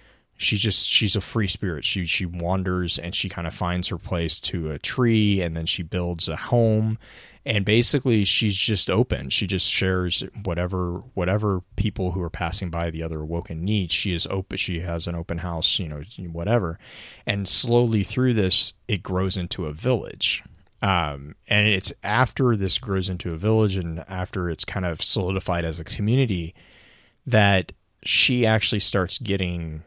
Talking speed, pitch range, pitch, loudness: 175 wpm, 85-105 Hz, 95 Hz, -23 LUFS